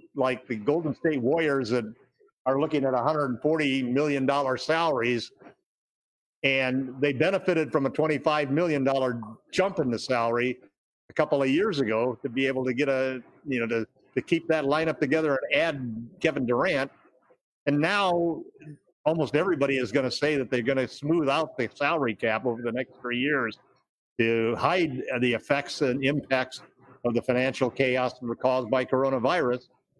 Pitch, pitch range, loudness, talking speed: 135 Hz, 125-150 Hz, -26 LUFS, 165 wpm